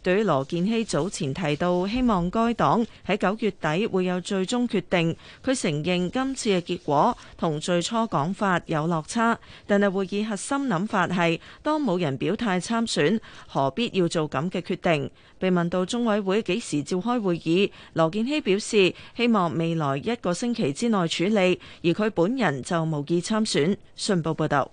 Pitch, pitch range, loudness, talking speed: 185 Hz, 170-220 Hz, -25 LUFS, 255 characters per minute